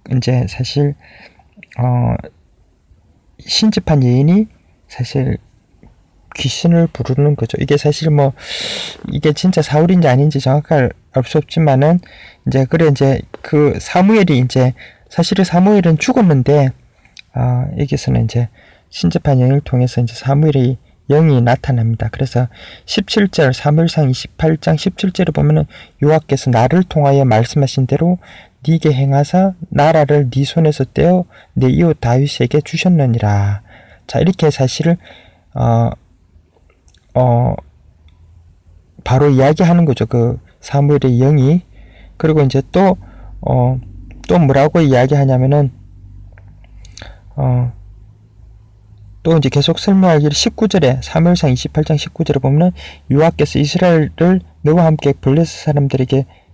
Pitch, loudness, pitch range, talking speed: 140 Hz, -14 LUFS, 120-155 Hz, 255 characters per minute